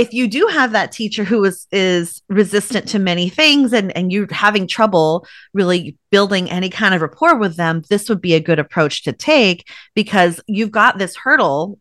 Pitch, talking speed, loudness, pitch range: 200 Hz, 200 wpm, -15 LUFS, 175-220 Hz